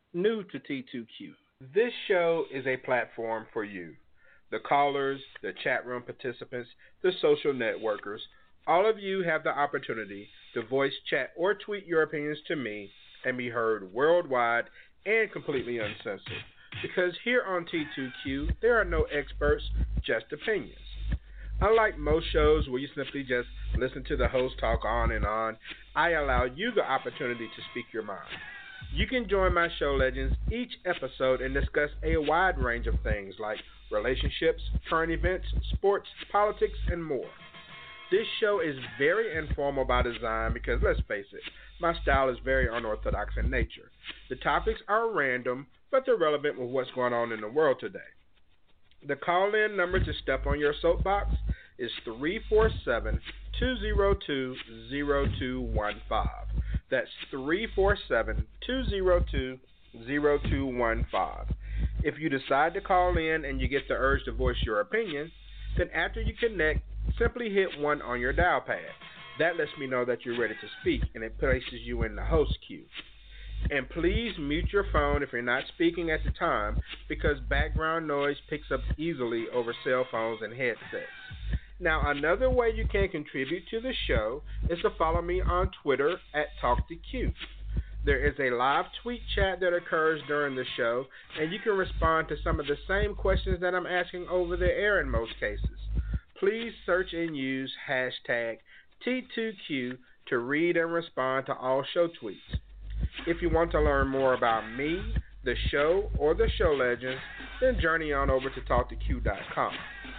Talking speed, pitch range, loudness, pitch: 160 wpm, 130-190 Hz, -29 LUFS, 150 Hz